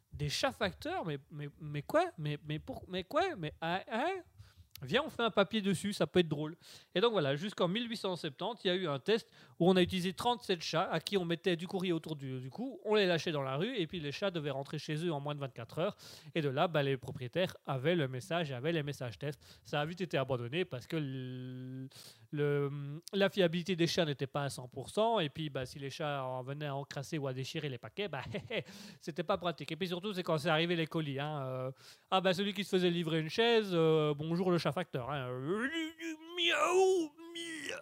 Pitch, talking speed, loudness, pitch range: 165 Hz, 240 wpm, -35 LUFS, 140-190 Hz